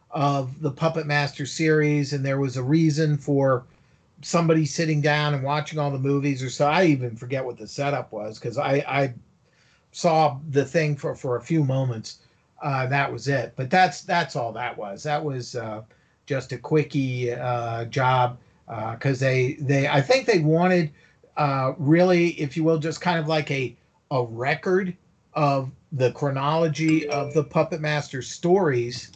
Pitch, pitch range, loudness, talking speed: 145 Hz, 130-155 Hz, -24 LUFS, 175 wpm